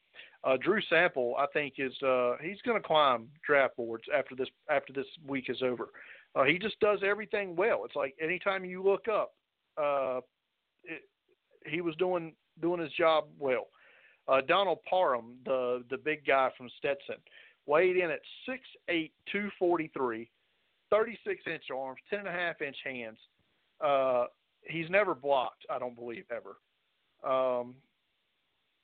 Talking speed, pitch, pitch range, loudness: 160 wpm, 155 Hz, 130-190 Hz, -31 LUFS